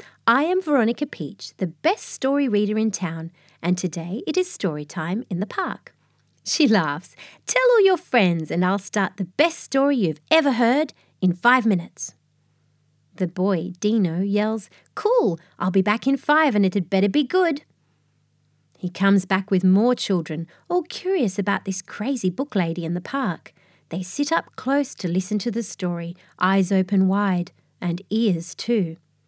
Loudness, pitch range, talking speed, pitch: -22 LUFS, 175-255 Hz, 170 wpm, 195 Hz